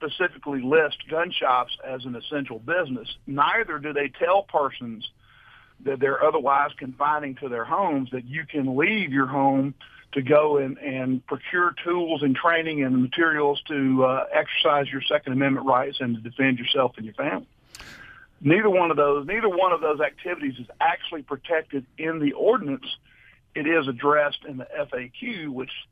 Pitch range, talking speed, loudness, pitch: 130-155 Hz, 165 wpm, -24 LUFS, 140 Hz